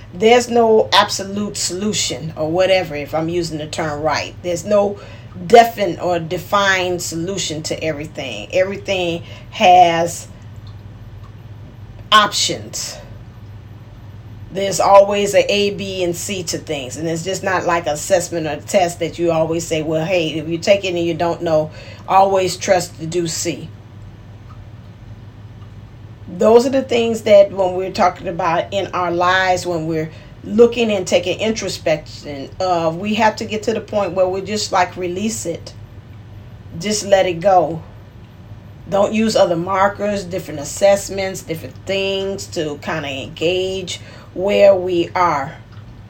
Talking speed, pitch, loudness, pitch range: 145 wpm, 170 Hz, -17 LUFS, 120-195 Hz